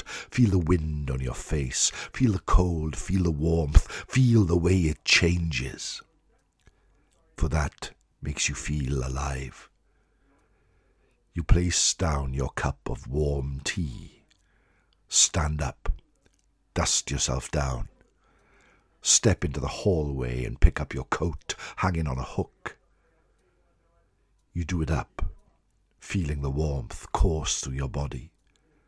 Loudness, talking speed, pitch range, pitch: -27 LUFS, 125 wpm, 70-90 Hz, 80 Hz